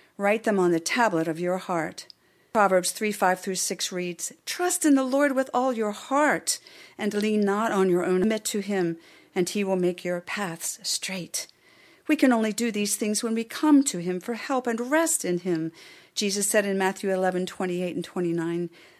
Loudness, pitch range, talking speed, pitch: -25 LUFS, 180-235 Hz, 205 wpm, 205 Hz